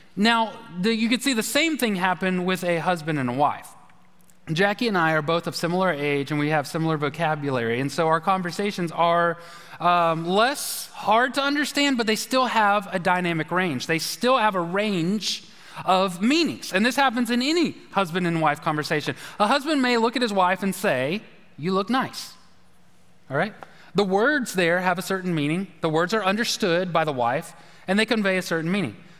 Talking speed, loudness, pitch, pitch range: 195 wpm, -23 LUFS, 185 Hz, 165-220 Hz